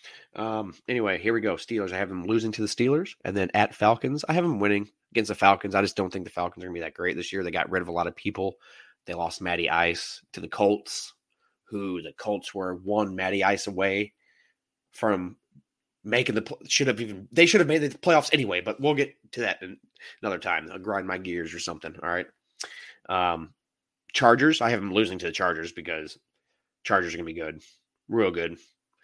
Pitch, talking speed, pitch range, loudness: 100 Hz, 220 wpm, 90-110 Hz, -26 LUFS